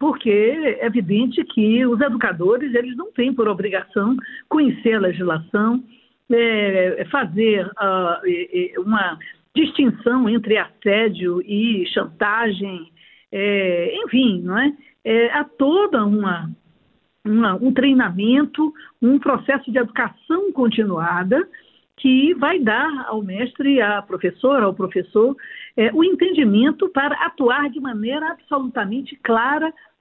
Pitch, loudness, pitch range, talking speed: 240 Hz, -19 LUFS, 210-285 Hz, 115 wpm